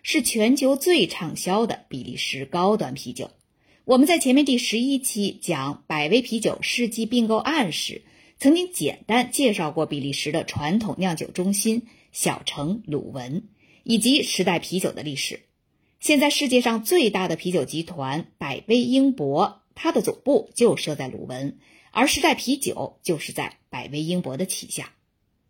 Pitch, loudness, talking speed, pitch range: 215 Hz, -23 LUFS, 245 characters per minute, 160-255 Hz